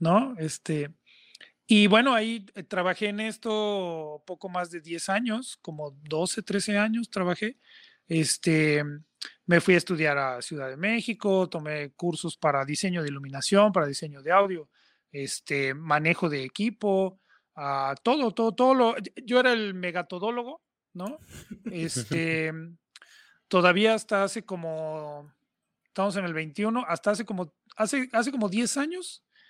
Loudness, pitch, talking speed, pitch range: -26 LUFS, 185 Hz, 140 wpm, 160-220 Hz